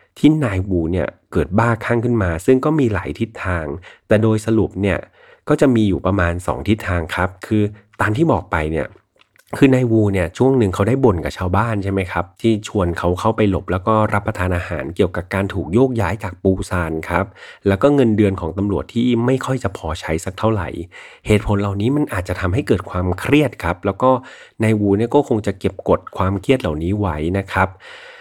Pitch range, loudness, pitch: 90-115 Hz, -18 LUFS, 100 Hz